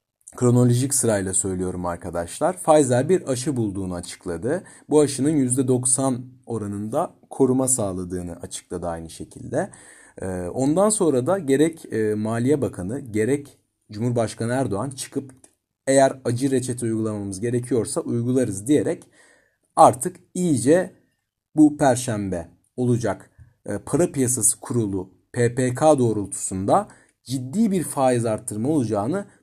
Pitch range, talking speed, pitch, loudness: 105-135 Hz, 100 wpm, 120 Hz, -22 LUFS